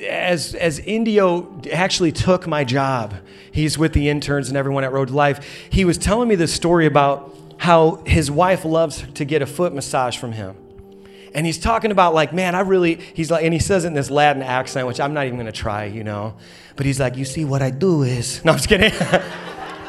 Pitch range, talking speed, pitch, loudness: 130-175 Hz, 225 wpm, 145 Hz, -18 LUFS